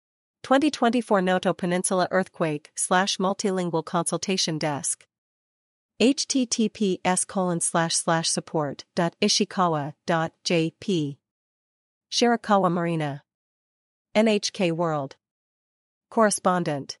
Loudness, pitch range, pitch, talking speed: -24 LUFS, 160-200 Hz, 180 Hz, 80 wpm